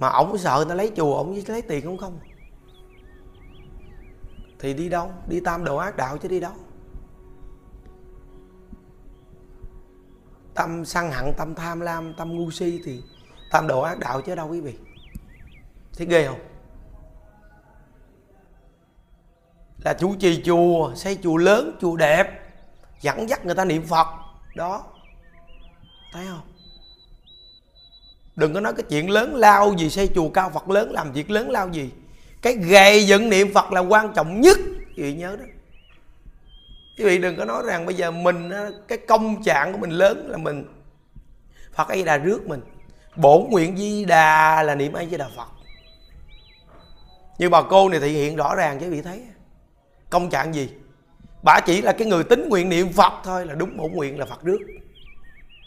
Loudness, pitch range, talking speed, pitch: -20 LUFS, 140-190 Hz, 170 wpm, 170 Hz